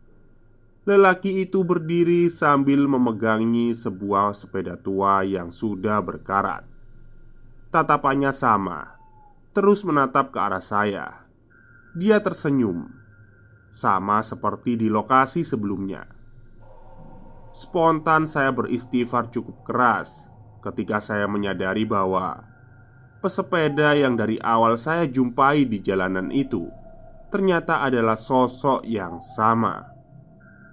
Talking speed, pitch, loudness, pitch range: 95 wpm, 120 Hz, -22 LUFS, 105-140 Hz